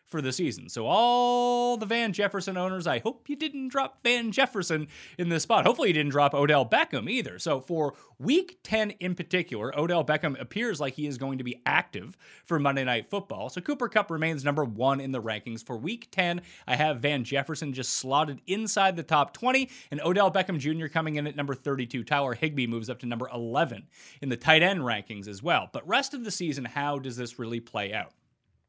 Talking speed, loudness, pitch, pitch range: 215 wpm, -28 LUFS, 155 Hz, 135-200 Hz